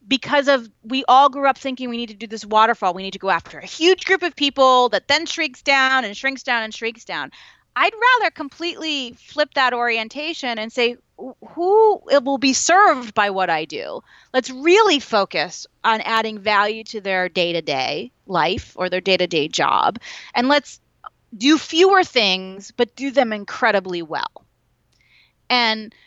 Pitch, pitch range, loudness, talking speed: 250 Hz, 215-290 Hz, -18 LUFS, 175 wpm